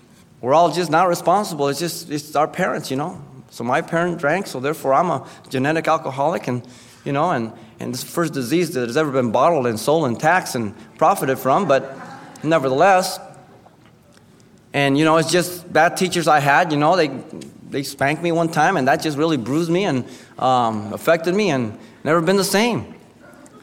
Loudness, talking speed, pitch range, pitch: -19 LUFS, 195 wpm, 135-170 Hz, 155 Hz